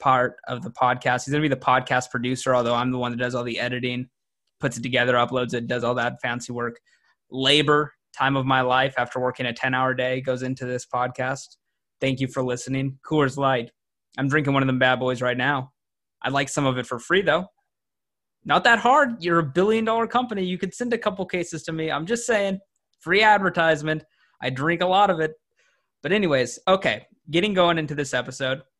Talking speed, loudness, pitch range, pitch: 215 wpm, -23 LUFS, 125-165 Hz, 135 Hz